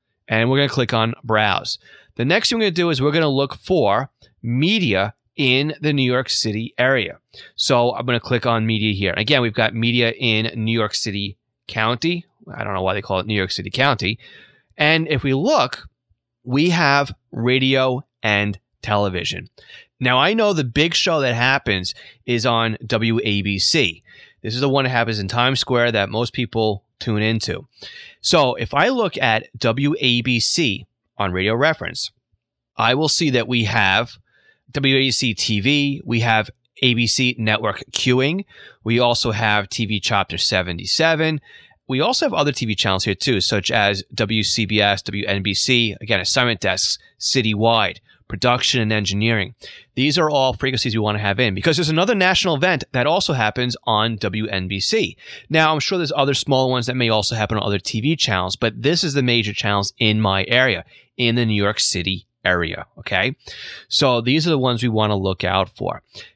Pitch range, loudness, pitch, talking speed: 105-135 Hz, -19 LUFS, 115 Hz, 180 wpm